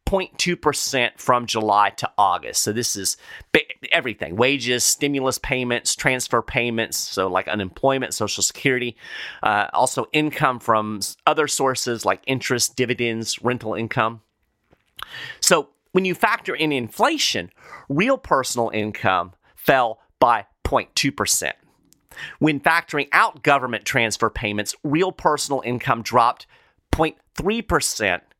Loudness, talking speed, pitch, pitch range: -21 LUFS, 115 wpm, 125 Hz, 110-140 Hz